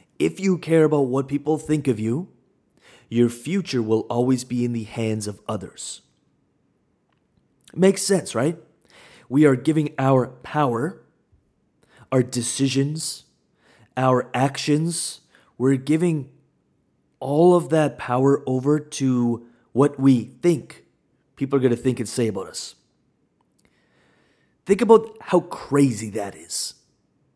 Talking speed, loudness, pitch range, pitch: 125 wpm, -22 LUFS, 120-155 Hz, 135 Hz